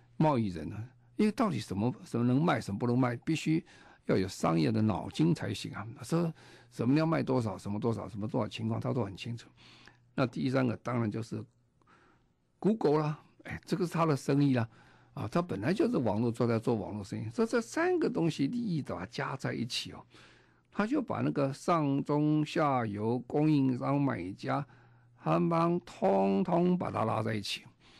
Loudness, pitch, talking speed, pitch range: -32 LUFS, 125 Hz, 285 characters per minute, 110-150 Hz